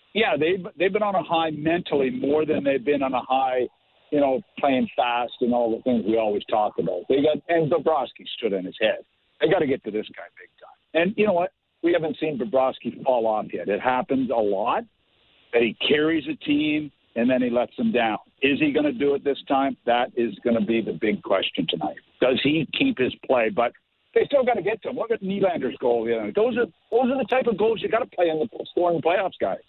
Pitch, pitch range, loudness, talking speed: 150 Hz, 125-190 Hz, -23 LUFS, 250 wpm